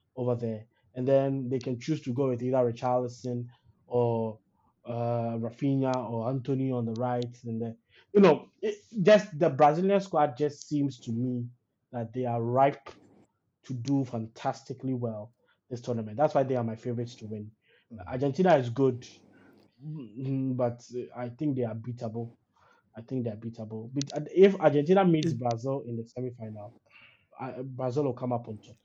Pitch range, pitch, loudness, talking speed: 115-135 Hz, 125 Hz, -29 LUFS, 165 wpm